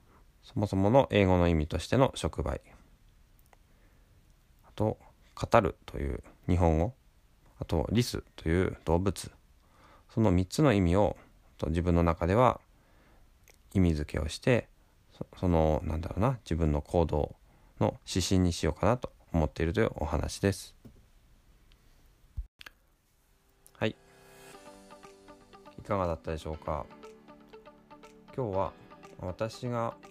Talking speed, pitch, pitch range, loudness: 215 characters per minute, 90 Hz, 80-100 Hz, -30 LUFS